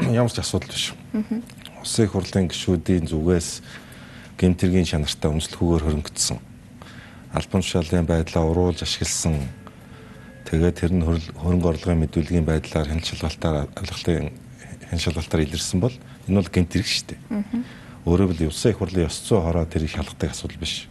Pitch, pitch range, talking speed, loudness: 85 Hz, 80-95 Hz, 140 wpm, -23 LUFS